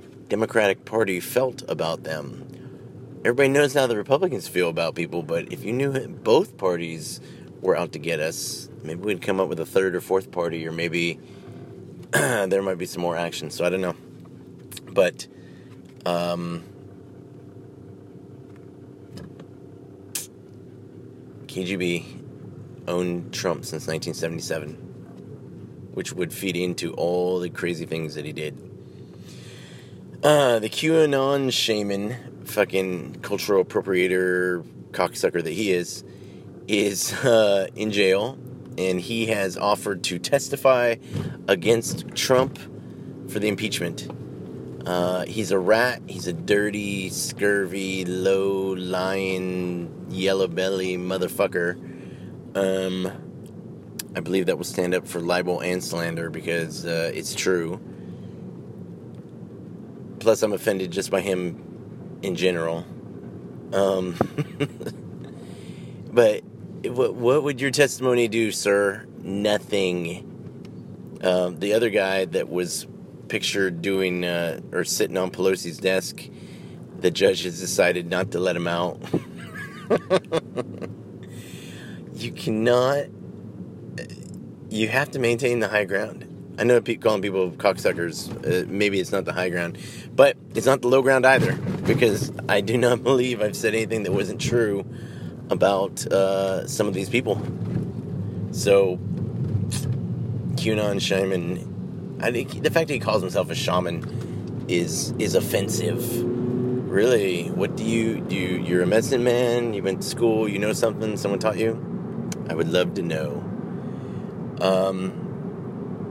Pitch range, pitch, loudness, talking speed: 90-120 Hz, 95 Hz, -24 LUFS, 130 wpm